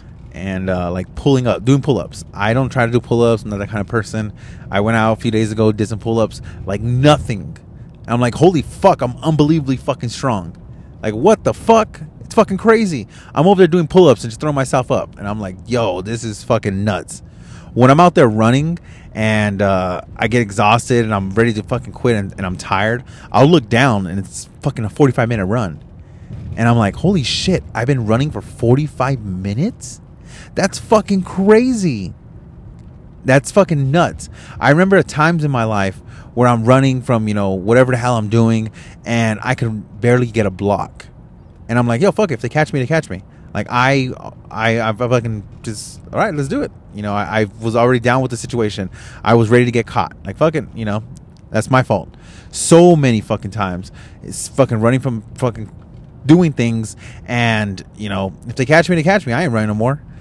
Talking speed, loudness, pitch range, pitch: 215 wpm, -16 LUFS, 105-135 Hz, 115 Hz